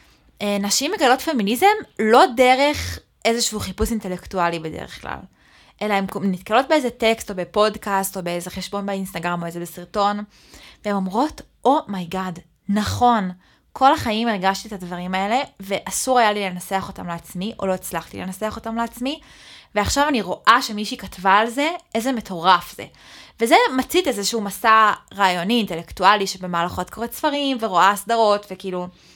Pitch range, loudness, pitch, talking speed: 185-235 Hz, -20 LUFS, 205 Hz, 140 wpm